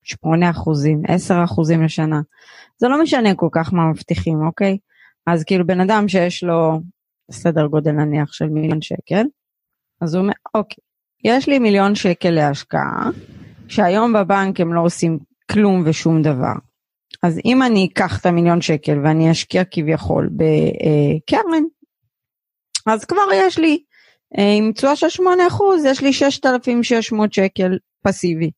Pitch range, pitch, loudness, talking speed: 160-230 Hz, 185 Hz, -17 LUFS, 135 wpm